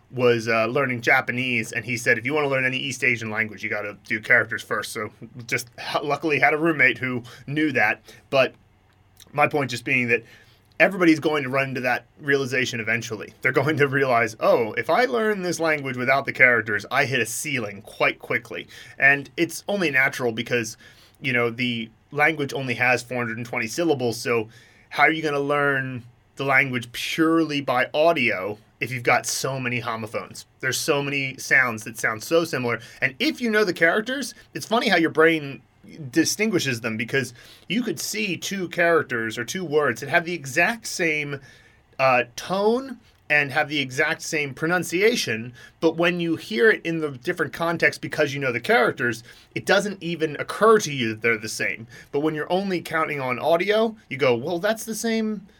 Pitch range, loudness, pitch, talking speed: 120-165 Hz, -22 LUFS, 140 Hz, 190 wpm